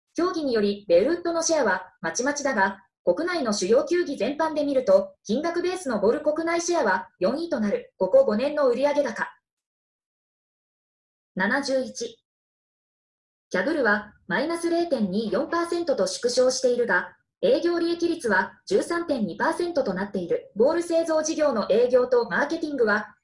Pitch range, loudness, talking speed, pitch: 210-335 Hz, -24 LUFS, 280 characters per minute, 285 Hz